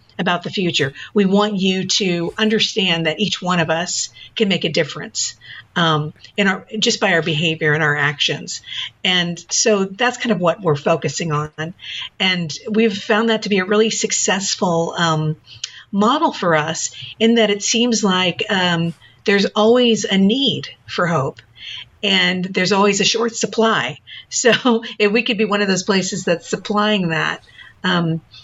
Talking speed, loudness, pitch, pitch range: 170 wpm, -17 LUFS, 190 Hz, 165-215 Hz